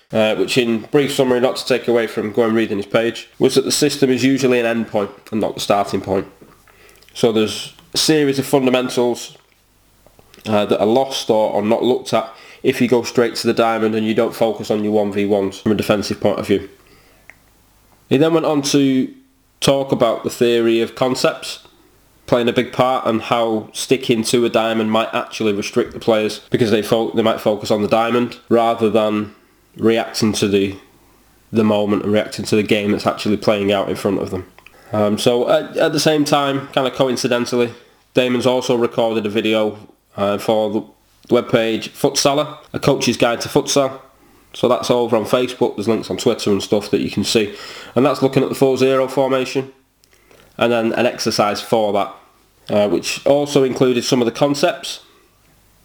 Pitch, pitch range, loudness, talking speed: 115 Hz, 110-130 Hz, -17 LUFS, 195 wpm